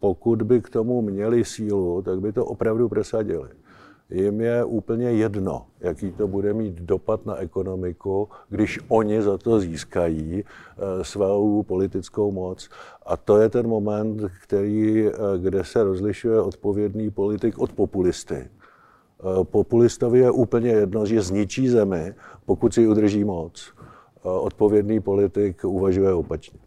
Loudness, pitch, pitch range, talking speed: -22 LUFS, 105 Hz, 95-110 Hz, 130 wpm